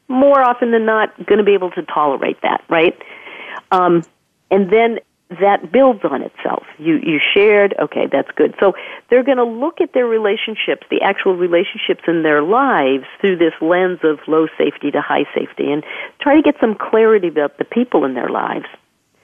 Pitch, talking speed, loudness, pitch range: 215 Hz, 185 wpm, -15 LUFS, 180-260 Hz